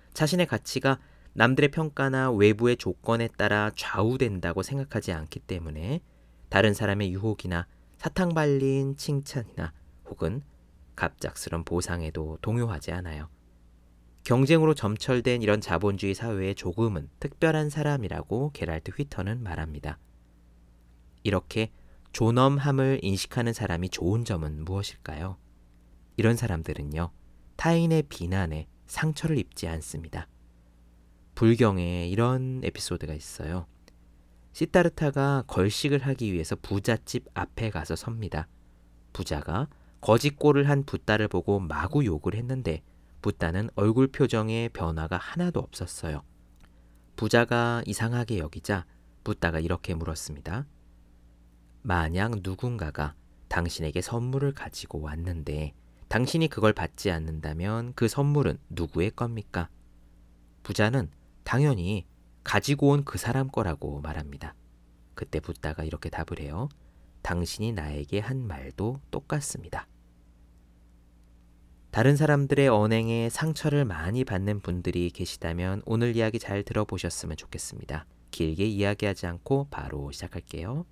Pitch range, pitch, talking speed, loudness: 75-120 Hz, 95 Hz, 285 characters per minute, -28 LUFS